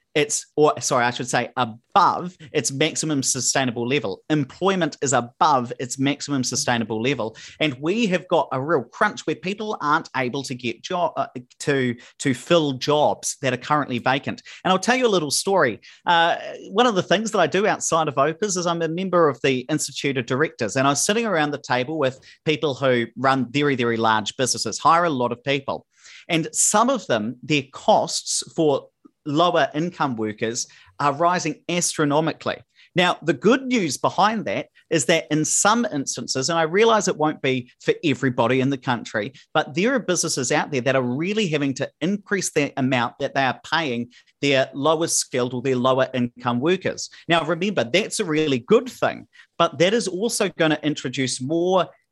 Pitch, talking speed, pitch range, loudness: 150 Hz, 190 wpm, 130-170 Hz, -21 LUFS